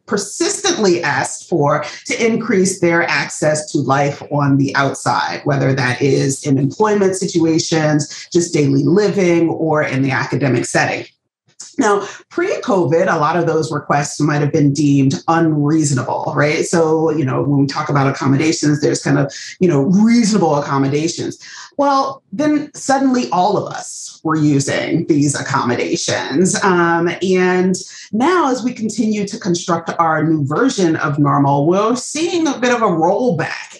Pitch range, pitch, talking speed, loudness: 145-200 Hz, 165 Hz, 150 wpm, -15 LUFS